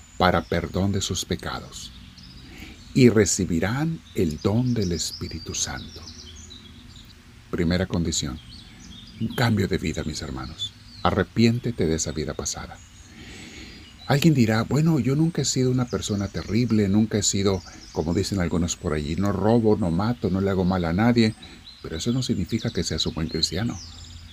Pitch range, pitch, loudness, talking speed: 80-115 Hz, 95 Hz, -24 LUFS, 155 wpm